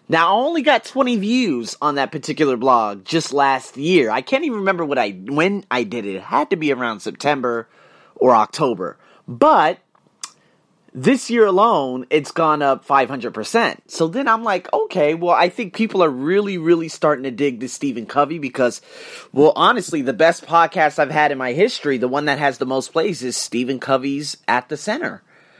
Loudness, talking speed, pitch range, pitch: -18 LUFS, 190 wpm, 135-185 Hz, 150 Hz